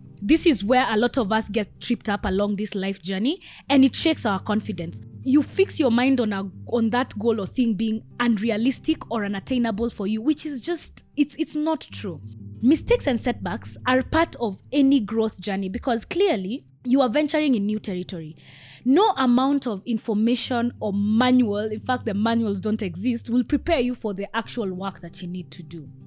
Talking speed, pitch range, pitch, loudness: 195 wpm, 205-265 Hz, 230 Hz, -23 LUFS